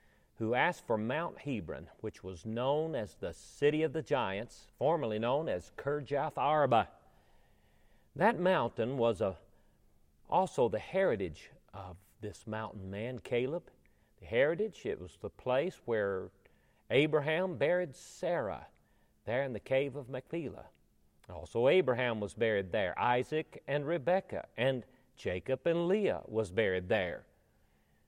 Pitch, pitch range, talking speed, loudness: 125 Hz, 100-155 Hz, 130 wpm, -34 LUFS